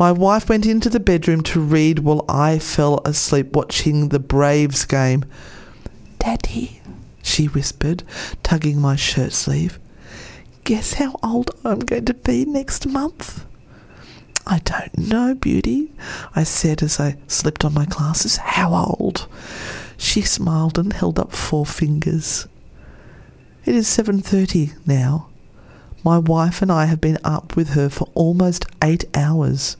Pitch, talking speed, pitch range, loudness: 155 Hz, 140 wpm, 145-180 Hz, -18 LUFS